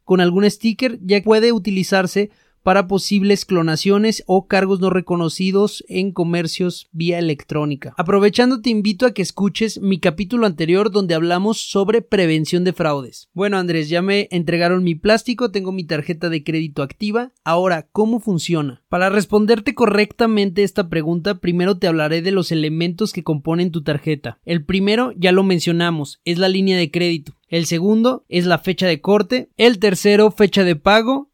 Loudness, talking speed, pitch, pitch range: -17 LUFS, 165 wpm, 190 Hz, 170-210 Hz